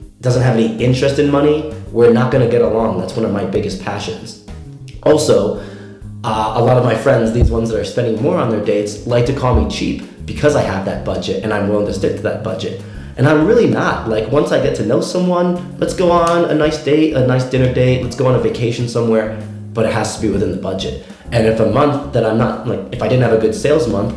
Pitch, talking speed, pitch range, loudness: 115 Hz, 255 wpm, 110-135 Hz, -15 LUFS